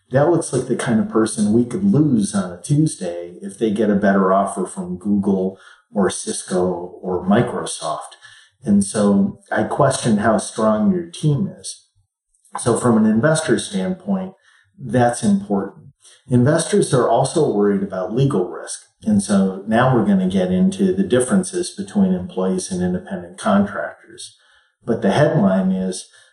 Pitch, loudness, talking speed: 130 Hz, -18 LUFS, 155 wpm